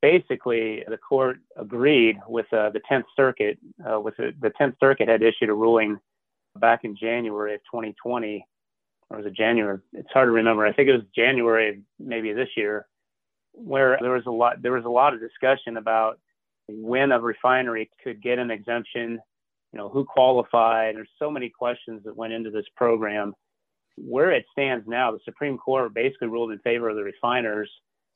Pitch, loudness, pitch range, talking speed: 115 Hz, -23 LUFS, 110-125 Hz, 185 wpm